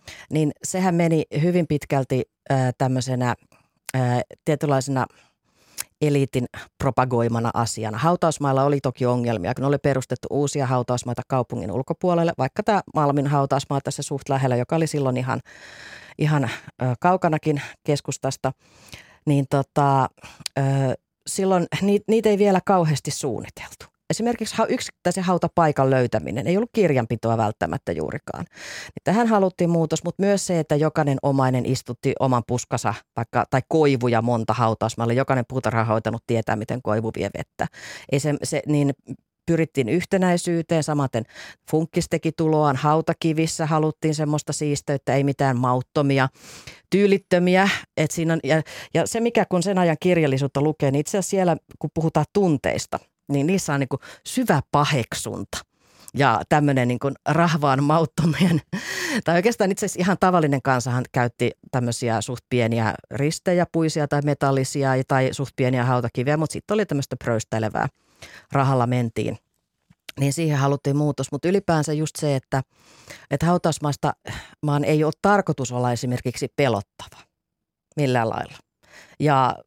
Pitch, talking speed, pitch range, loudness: 145 Hz, 130 wpm, 130-165 Hz, -22 LUFS